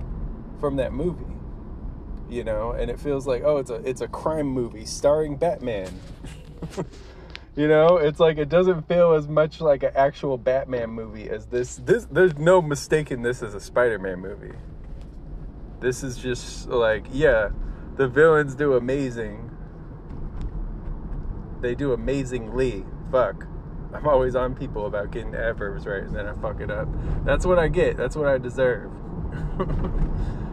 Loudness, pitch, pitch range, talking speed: -23 LUFS, 130 Hz, 115-150 Hz, 155 wpm